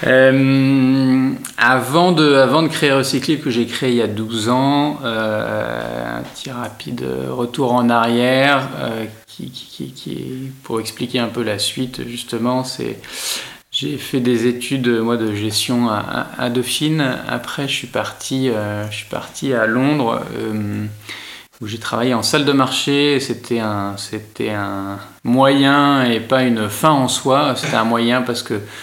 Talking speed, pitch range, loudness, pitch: 165 wpm, 110-135 Hz, -17 LUFS, 125 Hz